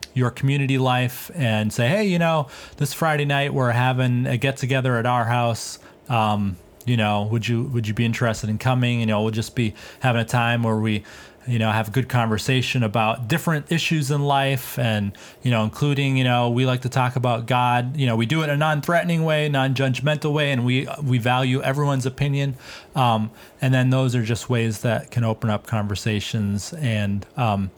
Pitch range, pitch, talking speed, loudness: 115-135 Hz, 125 Hz, 205 wpm, -22 LUFS